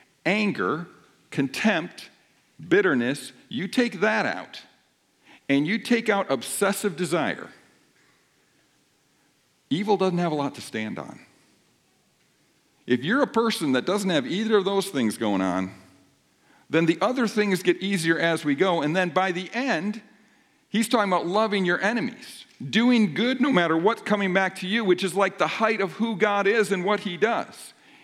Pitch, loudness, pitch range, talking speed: 195 Hz, -24 LUFS, 175-220 Hz, 165 wpm